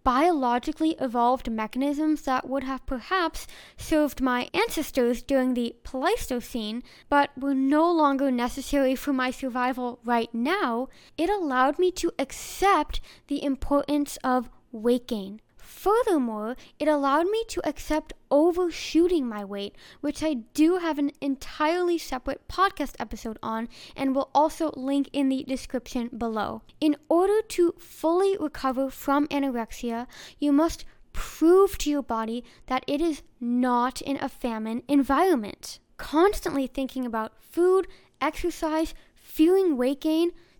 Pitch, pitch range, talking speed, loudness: 280 Hz, 250-320 Hz, 130 wpm, -26 LUFS